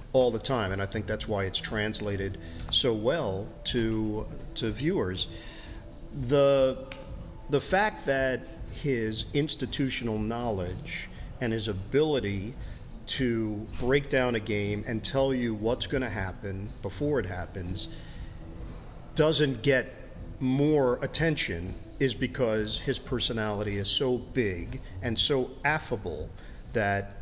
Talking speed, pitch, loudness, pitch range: 120 wpm, 115 Hz, -29 LUFS, 100-130 Hz